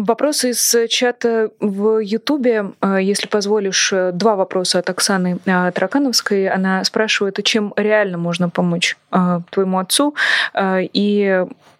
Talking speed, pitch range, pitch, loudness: 105 wpm, 185-225 Hz, 205 Hz, -16 LUFS